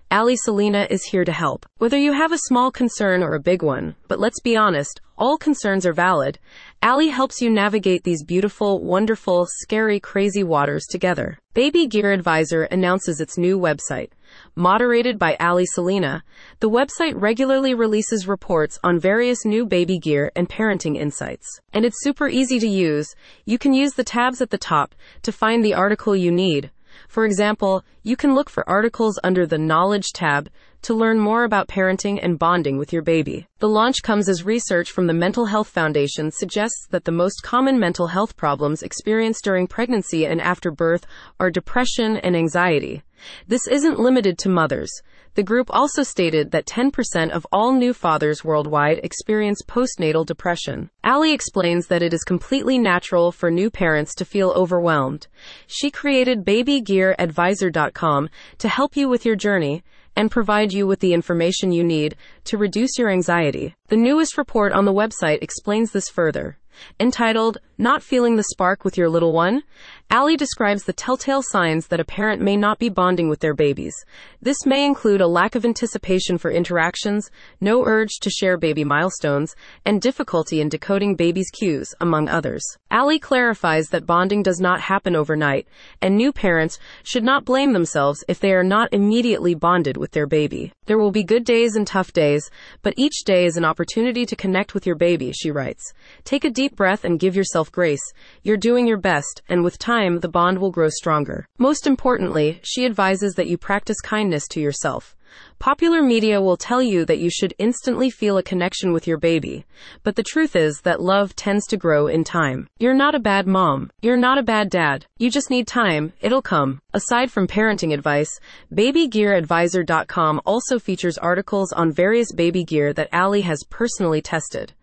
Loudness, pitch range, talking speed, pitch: -19 LUFS, 170-230 Hz, 180 wpm, 195 Hz